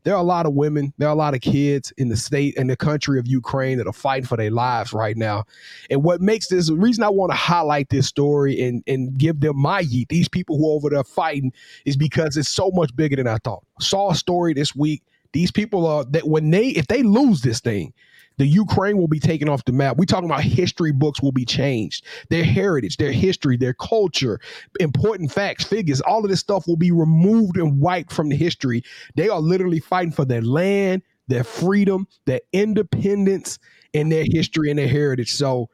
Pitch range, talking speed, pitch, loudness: 135-180 Hz, 225 wpm, 150 Hz, -20 LUFS